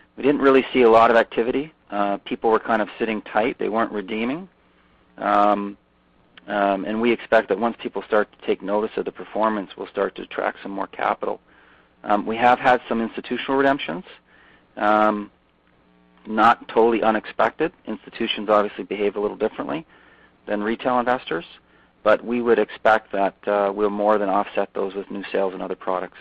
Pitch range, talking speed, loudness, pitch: 100-115 Hz, 175 wpm, -22 LUFS, 105 Hz